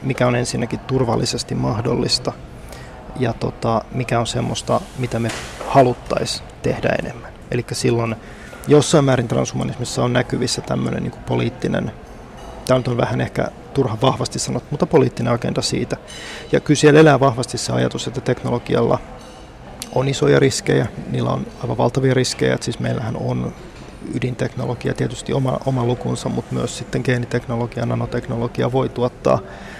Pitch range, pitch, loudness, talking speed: 115-130 Hz, 125 Hz, -19 LUFS, 140 wpm